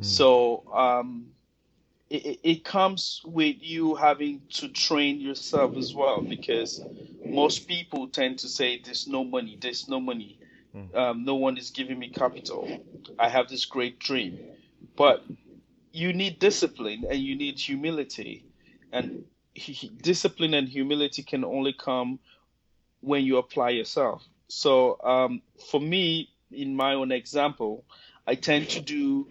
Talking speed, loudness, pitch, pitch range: 145 wpm, -26 LUFS, 135 Hz, 125-160 Hz